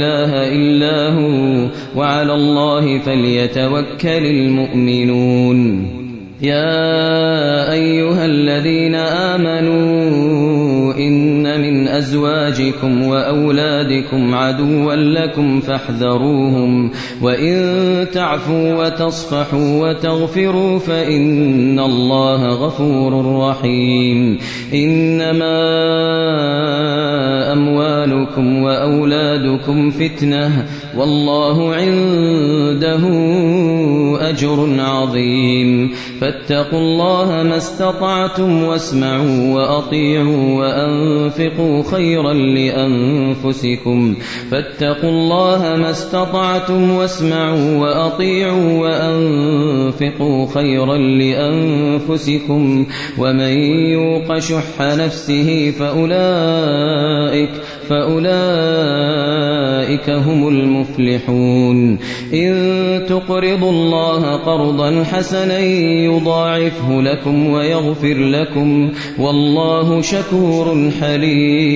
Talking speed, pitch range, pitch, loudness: 55 wpm, 135-160 Hz, 145 Hz, -14 LUFS